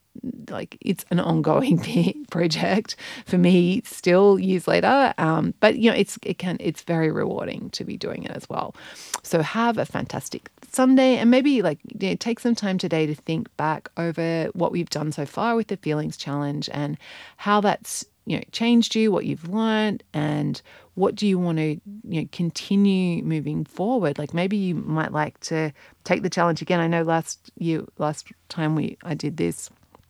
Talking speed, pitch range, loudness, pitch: 185 wpm, 155-215 Hz, -23 LUFS, 180 Hz